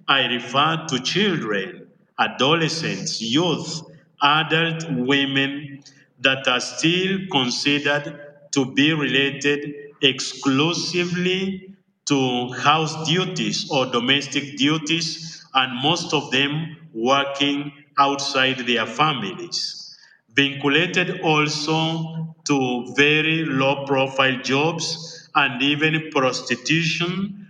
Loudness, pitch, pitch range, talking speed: -20 LUFS, 145 Hz, 135-165 Hz, 85 wpm